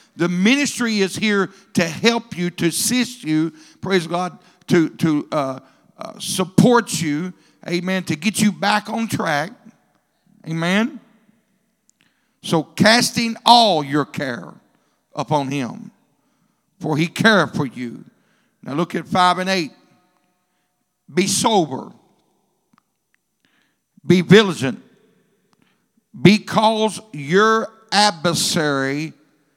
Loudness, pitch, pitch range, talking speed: -18 LUFS, 195 Hz, 170-220 Hz, 105 wpm